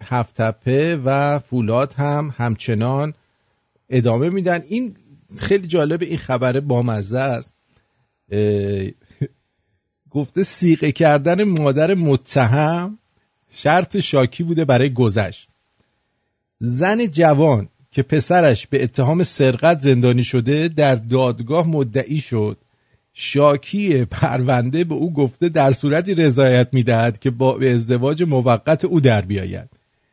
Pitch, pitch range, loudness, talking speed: 135 Hz, 120-160 Hz, -18 LUFS, 110 wpm